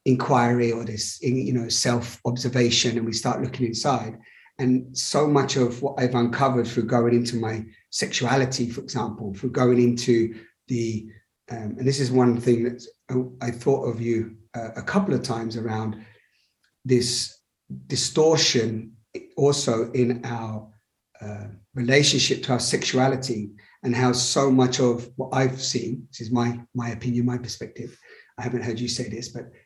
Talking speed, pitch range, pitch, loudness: 160 wpm, 115-130 Hz, 120 Hz, -23 LUFS